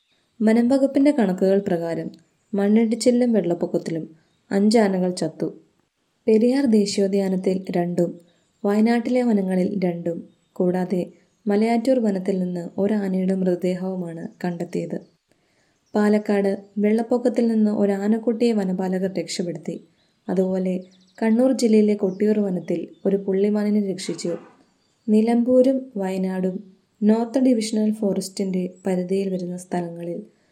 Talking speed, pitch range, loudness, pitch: 85 wpm, 185-220 Hz, -22 LUFS, 195 Hz